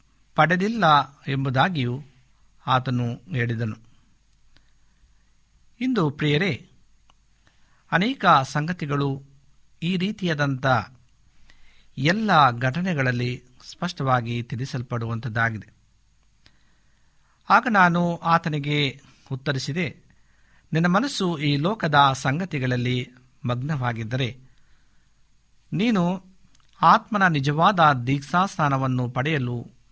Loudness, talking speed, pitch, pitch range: -23 LUFS, 60 wpm, 140 Hz, 125-165 Hz